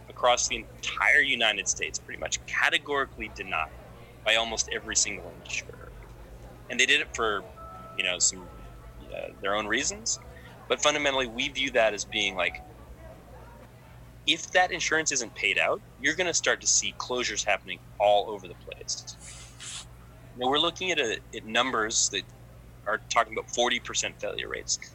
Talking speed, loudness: 160 wpm, -26 LUFS